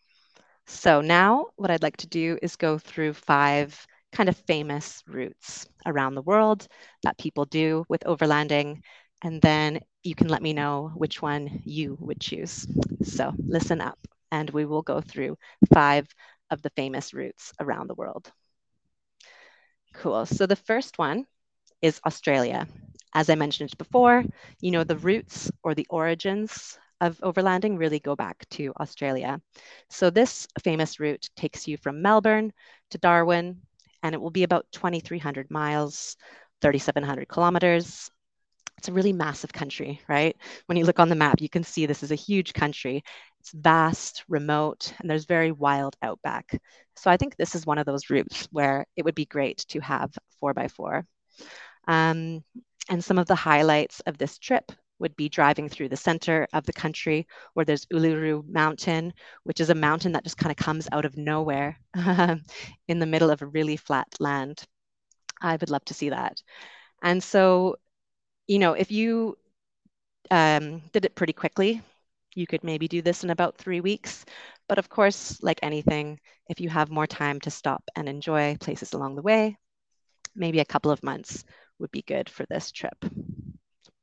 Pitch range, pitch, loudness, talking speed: 150-180 Hz, 160 Hz, -25 LUFS, 170 wpm